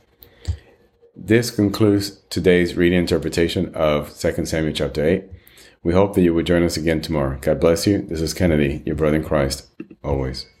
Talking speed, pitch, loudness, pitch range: 170 wpm, 85 Hz, -20 LUFS, 75-95 Hz